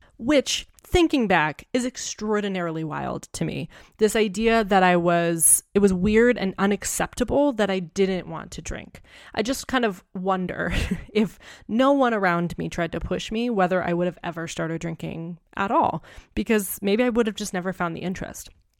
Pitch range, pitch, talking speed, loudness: 175-225 Hz, 195 Hz, 180 wpm, -23 LUFS